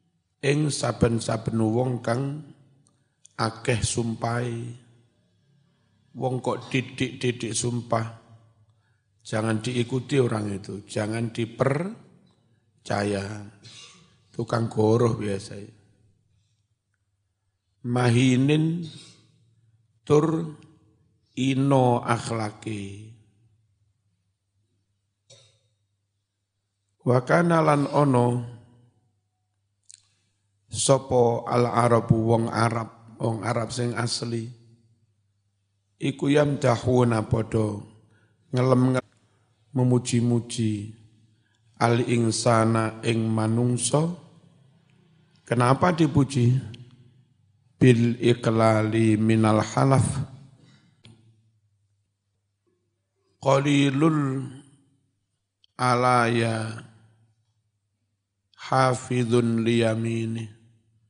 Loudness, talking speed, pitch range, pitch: -24 LUFS, 55 wpm, 110-125 Hz, 115 Hz